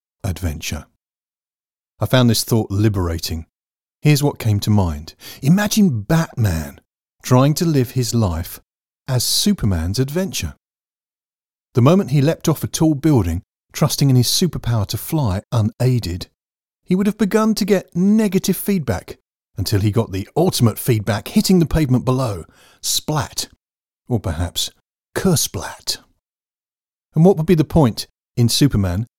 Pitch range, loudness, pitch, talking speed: 100-160 Hz, -18 LUFS, 120 Hz, 135 wpm